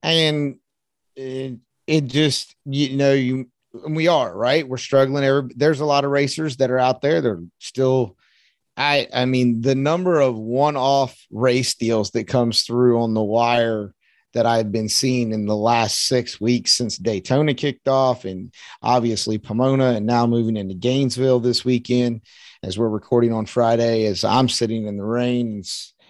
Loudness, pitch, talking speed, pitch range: -20 LUFS, 125 Hz, 170 wpm, 115-135 Hz